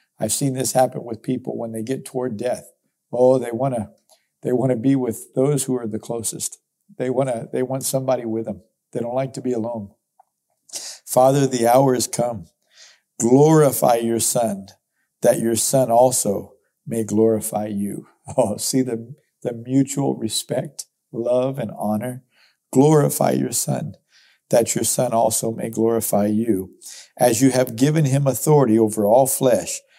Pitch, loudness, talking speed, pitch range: 125 Hz, -20 LUFS, 160 wpm, 110-130 Hz